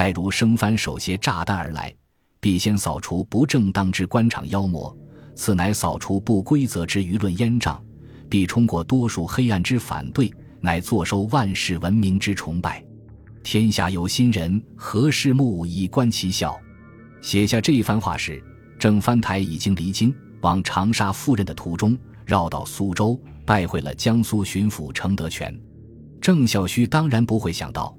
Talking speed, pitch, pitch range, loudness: 240 characters per minute, 105 Hz, 95-115 Hz, -22 LUFS